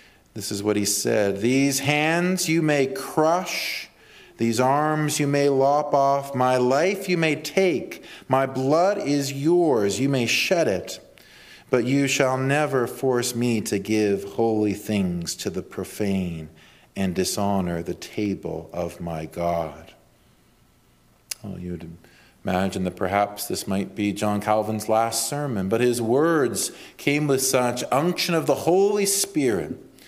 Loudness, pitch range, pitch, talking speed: -23 LUFS, 100-145 Hz, 120 Hz, 145 wpm